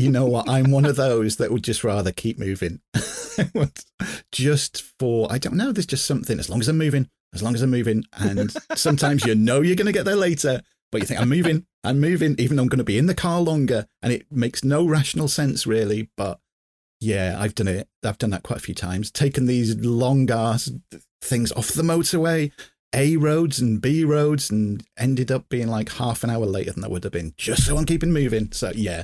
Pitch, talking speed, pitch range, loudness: 125 Hz, 225 wpm, 110-150 Hz, -22 LUFS